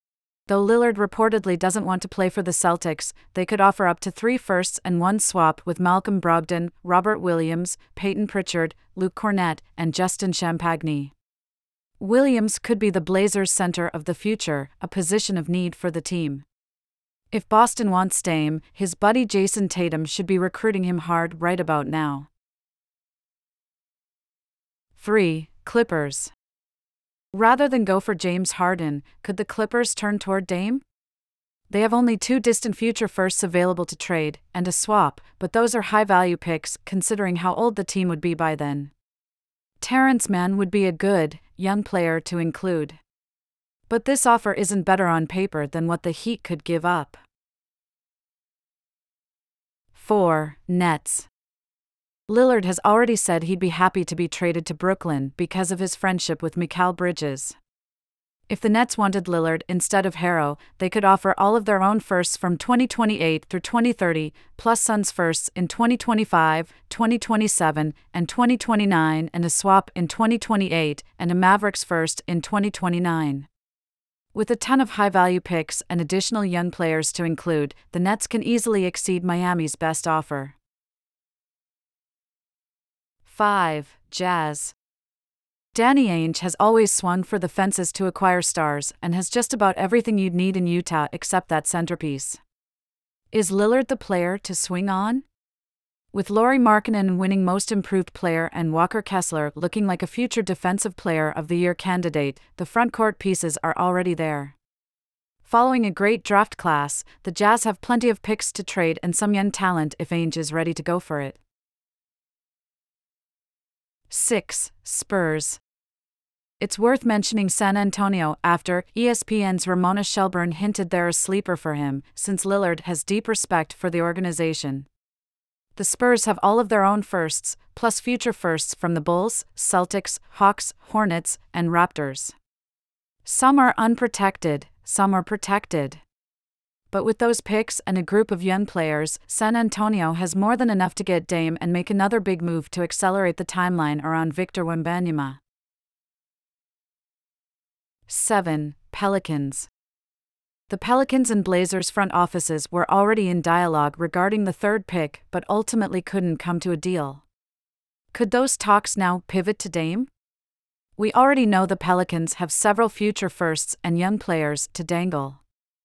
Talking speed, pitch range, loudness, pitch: 150 wpm, 165-205 Hz, -22 LUFS, 180 Hz